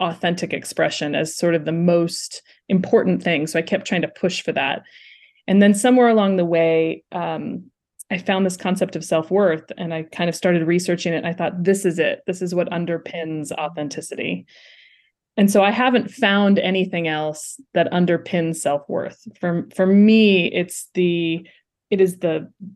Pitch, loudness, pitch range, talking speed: 175 Hz, -20 LUFS, 165-195 Hz, 180 wpm